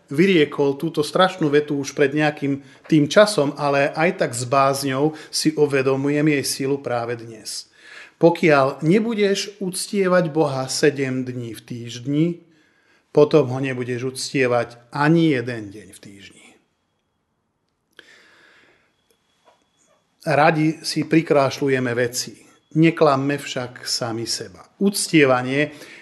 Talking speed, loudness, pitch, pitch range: 105 wpm, -20 LUFS, 145 Hz, 130-160 Hz